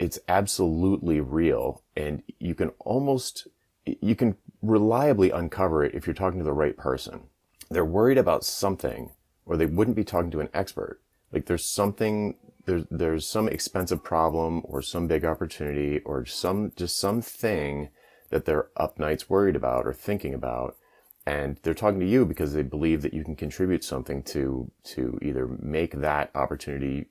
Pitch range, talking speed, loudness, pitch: 75-100 Hz, 165 wpm, -27 LUFS, 80 Hz